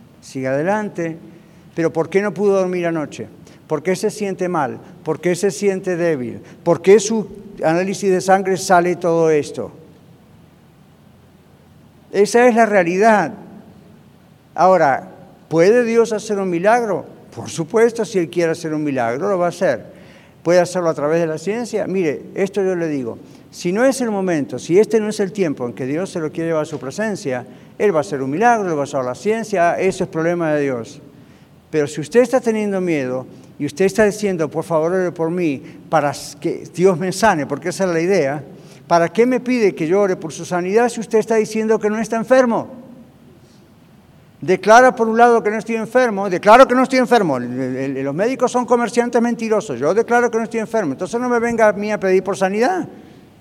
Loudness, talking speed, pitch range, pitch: -17 LUFS, 200 wpm, 160-215 Hz, 185 Hz